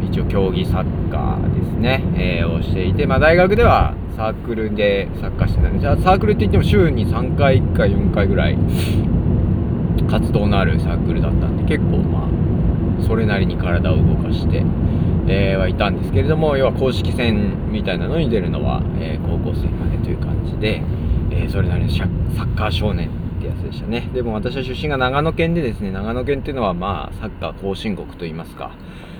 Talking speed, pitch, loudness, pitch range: 370 characters per minute, 90 Hz, -18 LUFS, 85-105 Hz